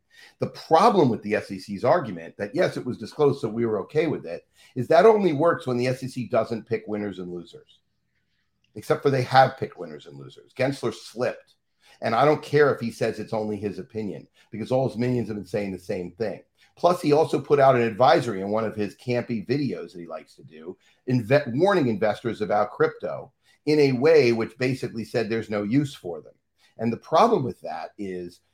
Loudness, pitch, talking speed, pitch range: -24 LUFS, 115 Hz, 210 wpm, 105-130 Hz